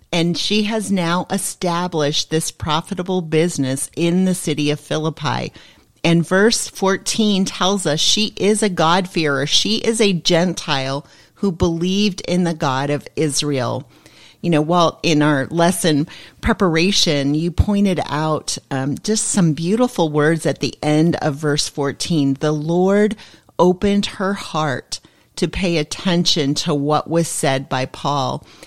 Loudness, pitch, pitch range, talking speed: -18 LUFS, 165 Hz, 150-190 Hz, 145 wpm